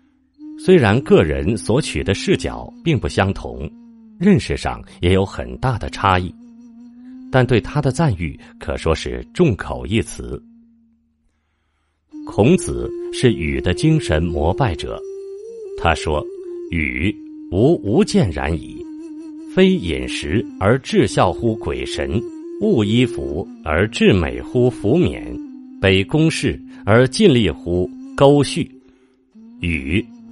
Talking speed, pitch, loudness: 160 characters per minute, 130 Hz, -18 LUFS